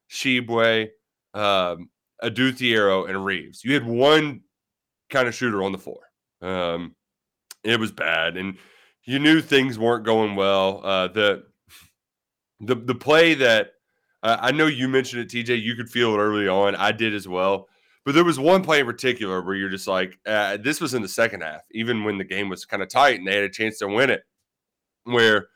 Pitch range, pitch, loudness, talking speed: 95-130 Hz, 110 Hz, -21 LUFS, 195 wpm